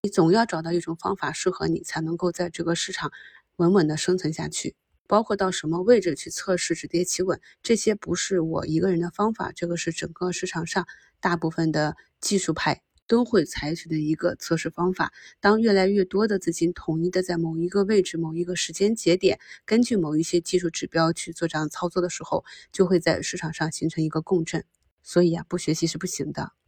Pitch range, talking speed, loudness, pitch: 165-185 Hz, 320 characters per minute, -25 LUFS, 175 Hz